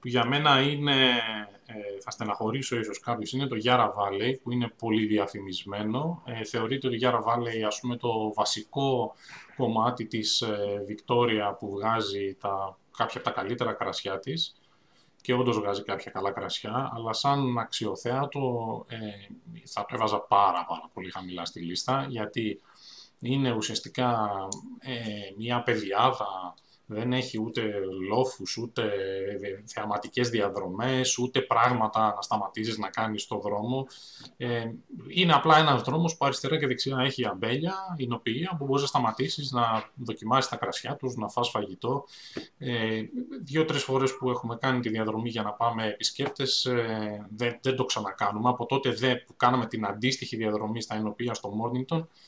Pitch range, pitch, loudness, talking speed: 105-130 Hz, 115 Hz, -28 LUFS, 140 wpm